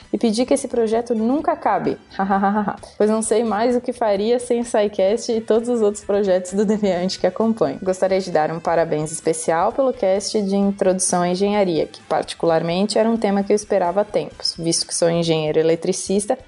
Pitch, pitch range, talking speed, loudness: 200 Hz, 180-225 Hz, 195 wpm, -19 LUFS